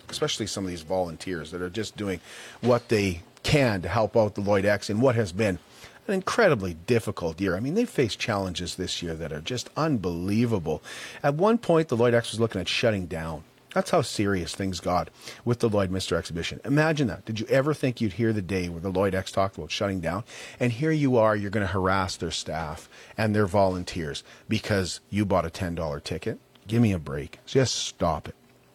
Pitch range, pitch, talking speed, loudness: 90-120 Hz, 105 Hz, 215 wpm, -26 LUFS